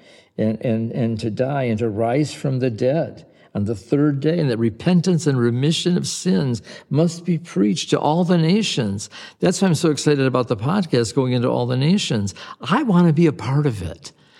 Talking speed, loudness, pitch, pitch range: 210 wpm, -20 LUFS, 145 Hz, 120-170 Hz